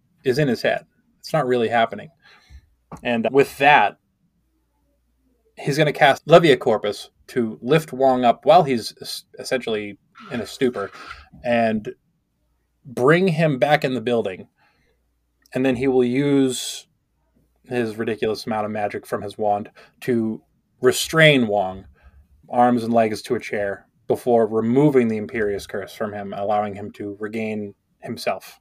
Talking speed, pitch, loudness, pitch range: 145 wpm, 115 Hz, -20 LUFS, 100-125 Hz